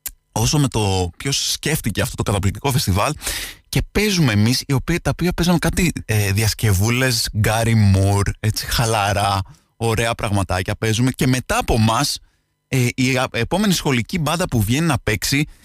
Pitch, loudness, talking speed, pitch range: 115 Hz, -19 LUFS, 140 wpm, 105-140 Hz